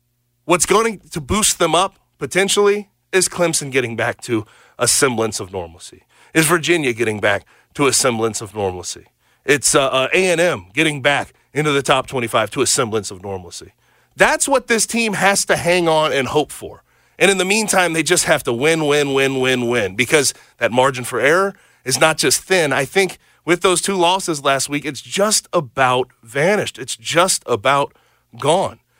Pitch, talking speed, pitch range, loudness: 155 Hz, 180 wpm, 125-180 Hz, -16 LUFS